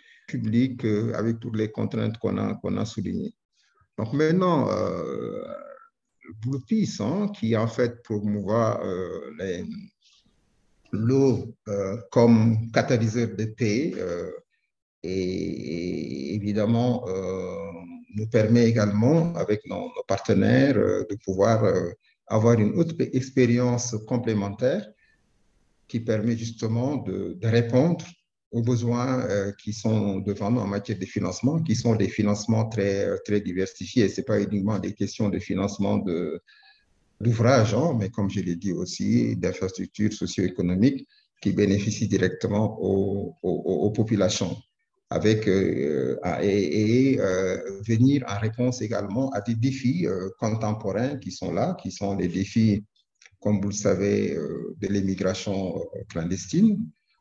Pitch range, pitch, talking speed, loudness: 100-125 Hz, 110 Hz, 140 wpm, -25 LUFS